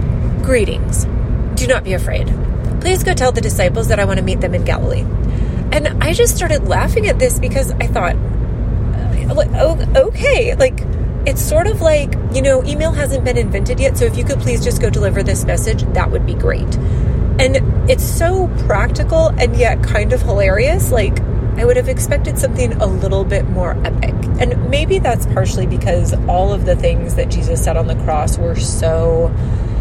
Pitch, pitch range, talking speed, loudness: 110 Hz, 100-120 Hz, 185 wpm, -15 LUFS